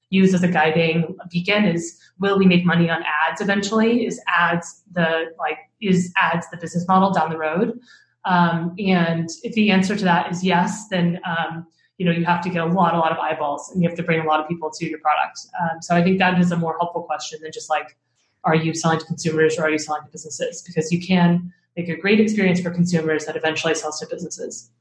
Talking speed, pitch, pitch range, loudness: 235 wpm, 170 Hz, 160-185 Hz, -20 LUFS